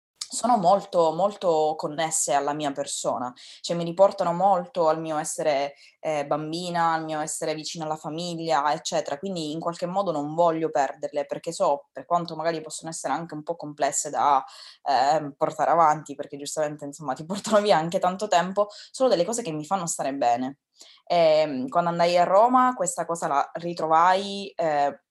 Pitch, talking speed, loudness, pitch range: 165 Hz, 170 wpm, -25 LUFS, 150-180 Hz